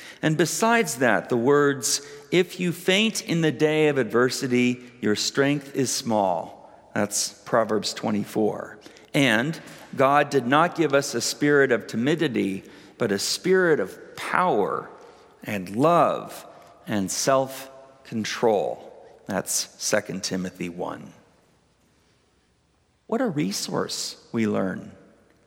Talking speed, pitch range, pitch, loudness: 115 wpm, 115-155 Hz, 135 Hz, -23 LUFS